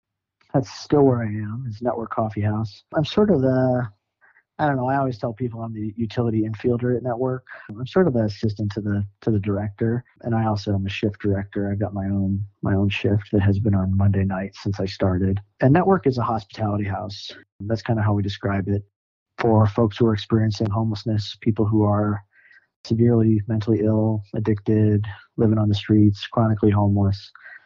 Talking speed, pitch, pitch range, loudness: 195 wpm, 110 Hz, 100-115 Hz, -22 LUFS